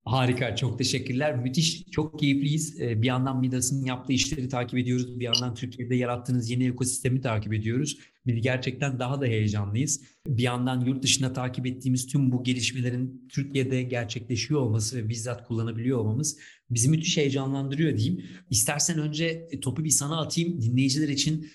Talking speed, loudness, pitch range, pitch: 150 wpm, -27 LUFS, 125-140 Hz, 130 Hz